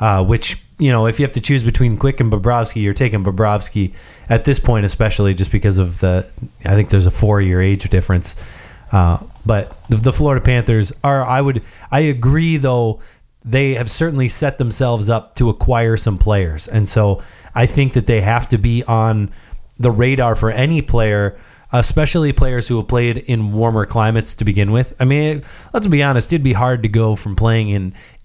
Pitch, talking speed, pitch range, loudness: 115 Hz, 195 wpm, 105-130 Hz, -16 LUFS